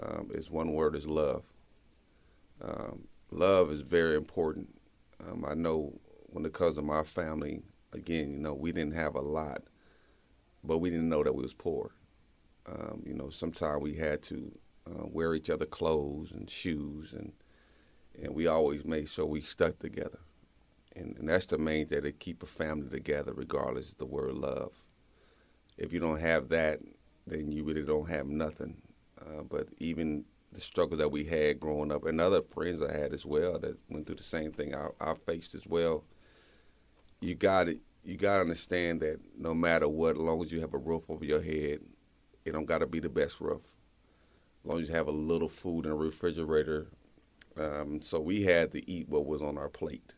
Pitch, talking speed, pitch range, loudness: 75 Hz, 195 wpm, 75-80 Hz, -33 LUFS